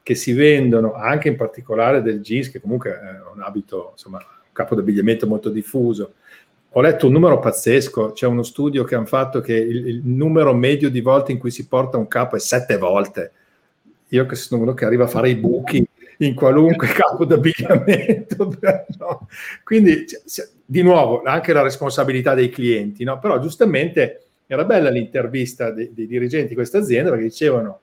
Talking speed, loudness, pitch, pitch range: 175 wpm, -17 LUFS, 130 Hz, 120-155 Hz